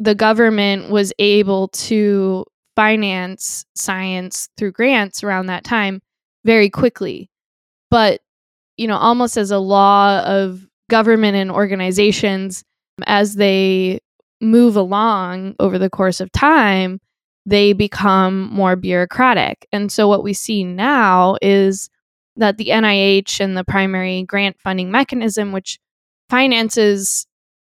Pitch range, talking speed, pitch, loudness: 190-215 Hz, 120 wpm, 200 Hz, -15 LUFS